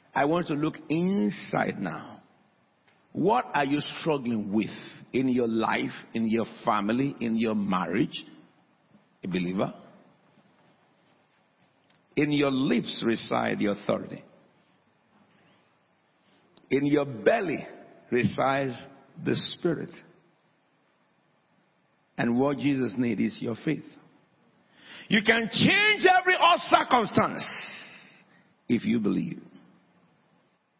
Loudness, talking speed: -26 LUFS, 95 wpm